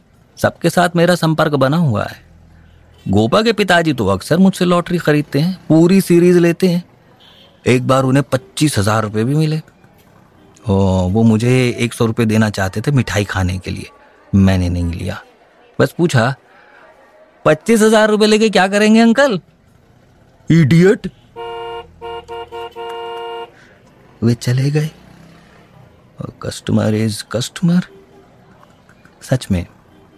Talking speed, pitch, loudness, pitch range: 125 wpm, 125 Hz, -14 LUFS, 110-170 Hz